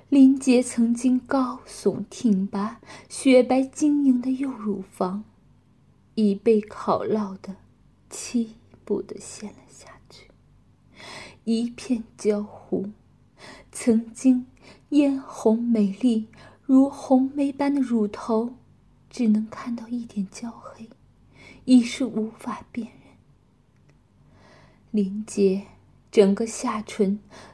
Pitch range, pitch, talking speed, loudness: 210-255 Hz, 230 Hz, 140 characters per minute, -24 LUFS